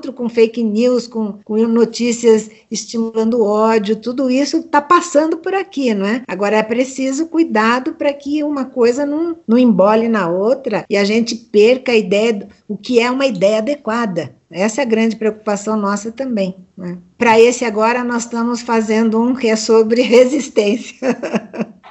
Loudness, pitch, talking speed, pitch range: -15 LUFS, 230 Hz, 165 wpm, 215-255 Hz